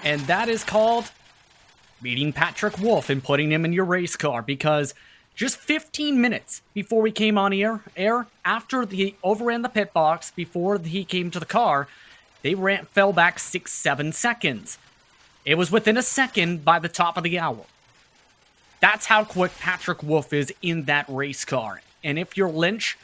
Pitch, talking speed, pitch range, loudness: 180 Hz, 175 wpm, 155-215 Hz, -23 LUFS